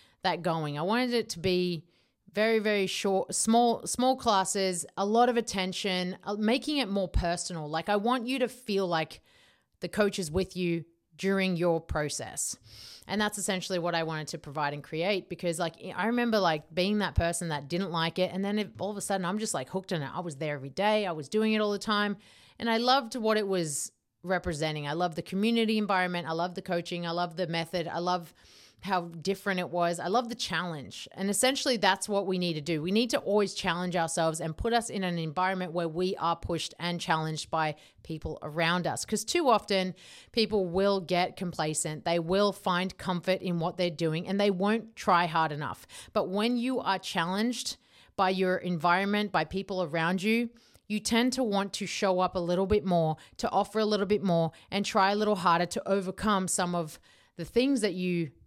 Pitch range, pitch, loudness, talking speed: 170-210 Hz, 185 Hz, -29 LUFS, 210 wpm